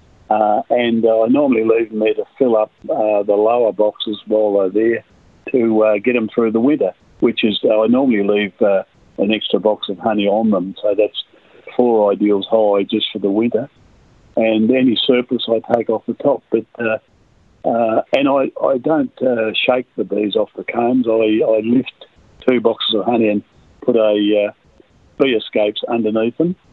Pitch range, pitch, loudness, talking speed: 105-115 Hz, 110 Hz, -16 LUFS, 190 wpm